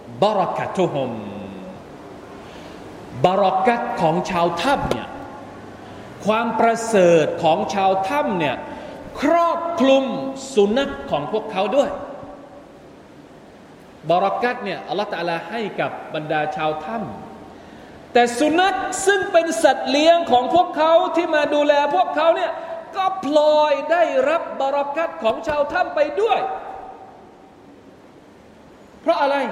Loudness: -19 LUFS